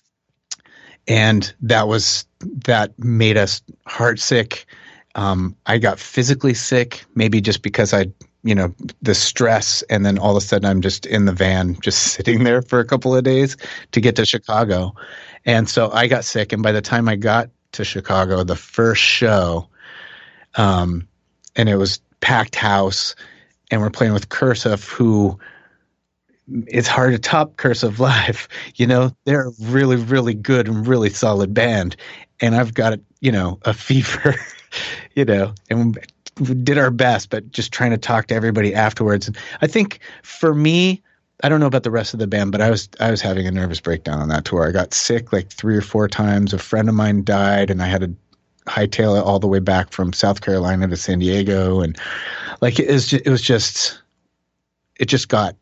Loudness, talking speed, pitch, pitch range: -17 LUFS, 190 wpm, 110 Hz, 100-120 Hz